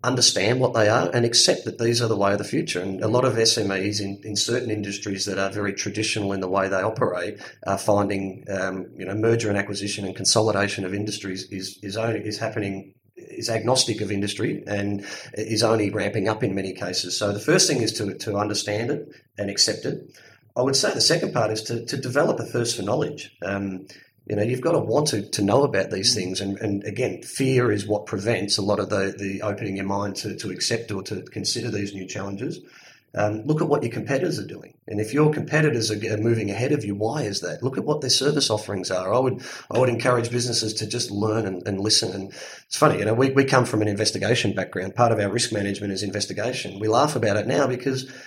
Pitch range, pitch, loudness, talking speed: 100-115 Hz, 105 Hz, -23 LUFS, 235 wpm